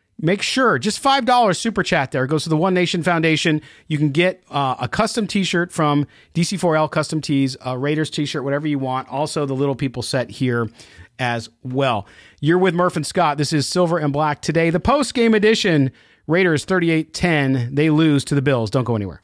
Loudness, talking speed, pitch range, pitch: -19 LUFS, 200 wpm, 135-180 Hz, 155 Hz